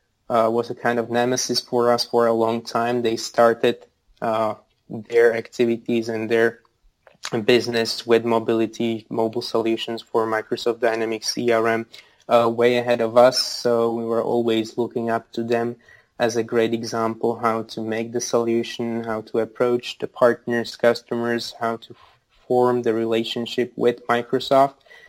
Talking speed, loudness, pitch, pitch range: 155 wpm, -21 LUFS, 115 Hz, 115-120 Hz